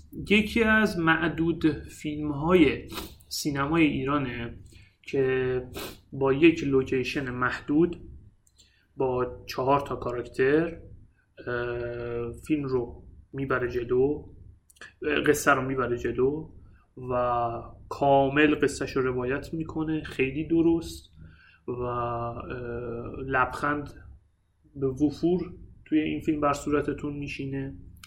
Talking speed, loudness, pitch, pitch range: 90 wpm, -27 LUFS, 130 Hz, 120-150 Hz